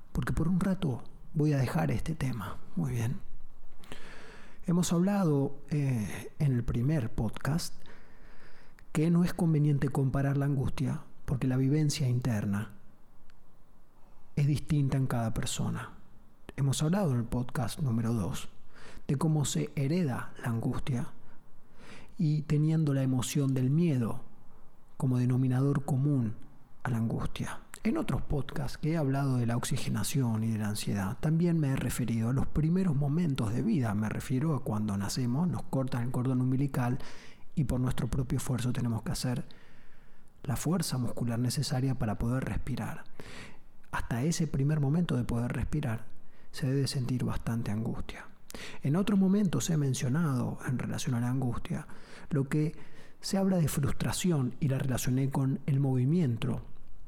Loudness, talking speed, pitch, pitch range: -31 LUFS, 150 wpm, 135 Hz, 125-150 Hz